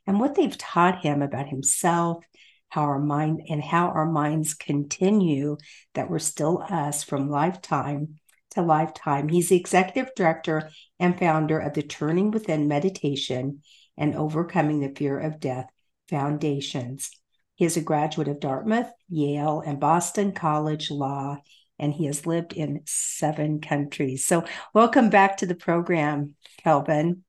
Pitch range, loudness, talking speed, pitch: 145-175 Hz, -25 LUFS, 145 wpm, 155 Hz